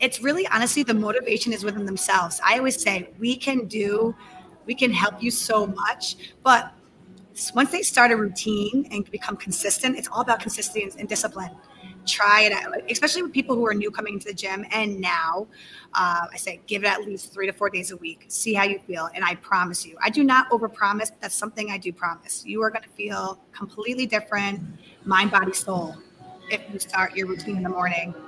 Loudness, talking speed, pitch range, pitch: -23 LUFS, 210 wpm, 185-225 Hz, 205 Hz